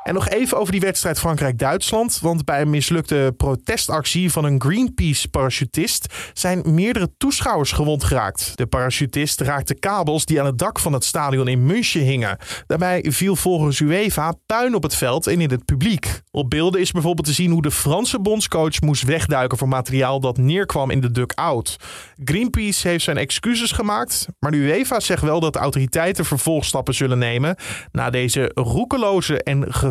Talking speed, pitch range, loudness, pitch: 175 wpm, 135-175 Hz, -19 LUFS, 150 Hz